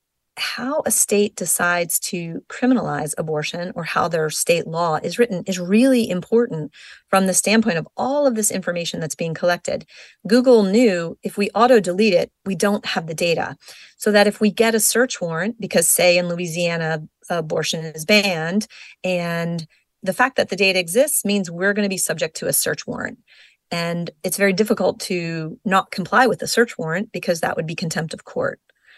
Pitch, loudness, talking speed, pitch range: 190 Hz, -19 LUFS, 185 wpm, 170-225 Hz